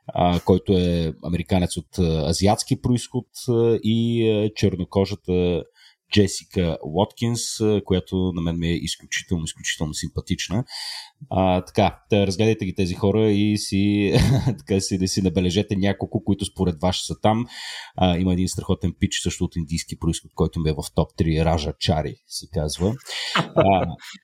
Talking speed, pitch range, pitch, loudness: 145 wpm, 85-105 Hz, 95 Hz, -22 LUFS